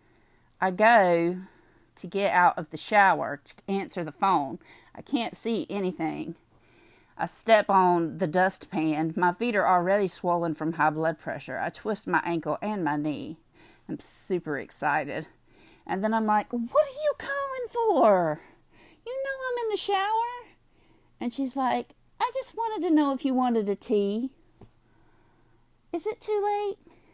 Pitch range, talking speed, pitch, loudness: 175-290 Hz, 160 wpm, 210 Hz, -26 LUFS